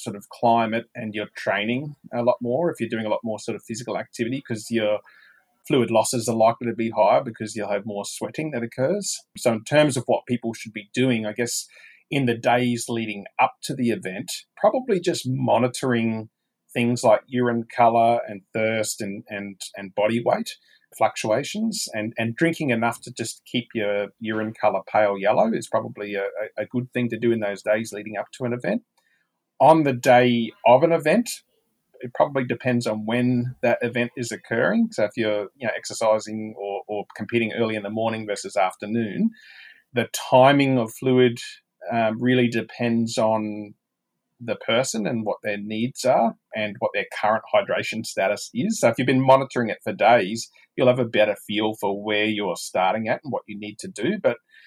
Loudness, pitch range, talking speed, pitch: -23 LUFS, 110-125 Hz, 190 wpm, 115 Hz